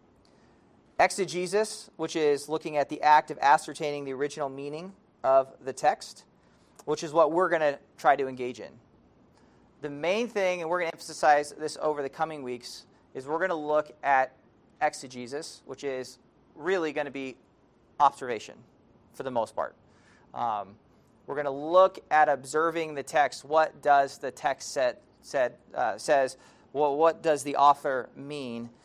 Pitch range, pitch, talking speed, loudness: 135-160 Hz, 150 Hz, 165 wpm, -28 LUFS